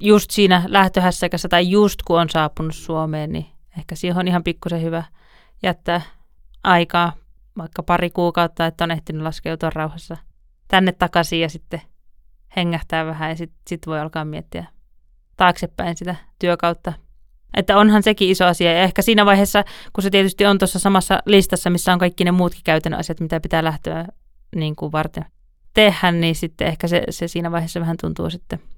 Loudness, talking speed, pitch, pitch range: -18 LUFS, 170 wpm, 175 Hz, 165-185 Hz